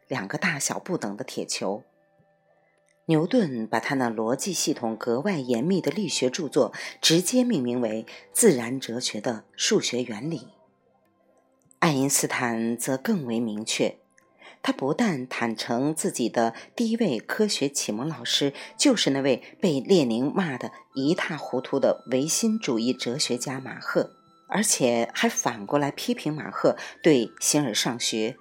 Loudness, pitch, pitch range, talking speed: -25 LUFS, 140 Hz, 120-190 Hz, 220 characters per minute